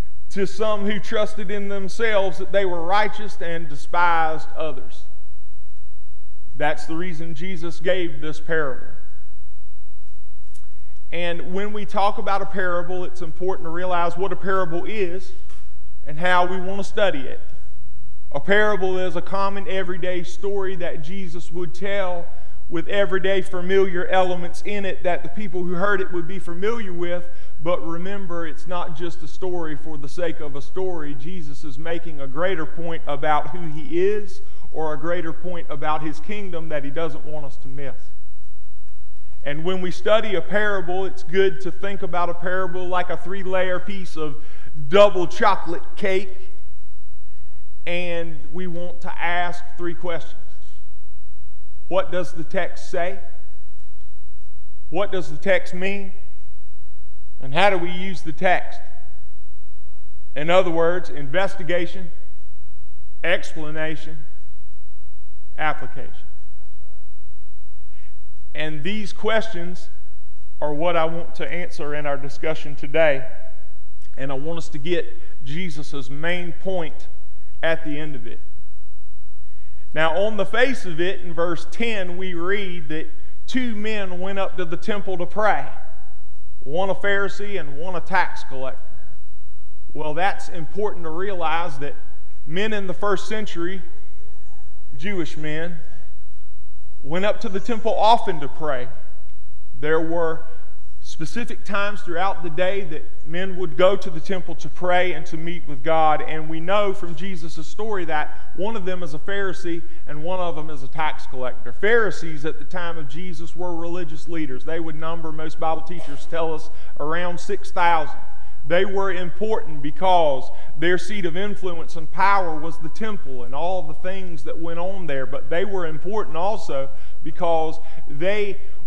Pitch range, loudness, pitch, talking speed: 130-185 Hz, -25 LUFS, 165 Hz, 150 wpm